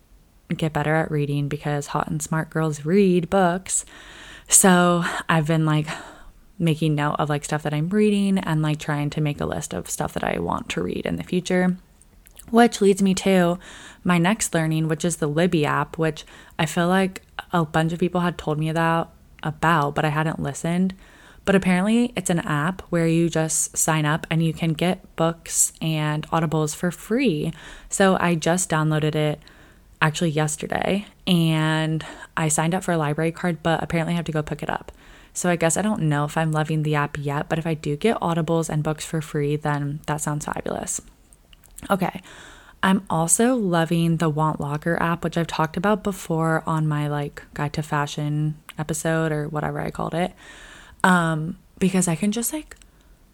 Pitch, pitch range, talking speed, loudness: 165 Hz, 155-180 Hz, 190 wpm, -22 LUFS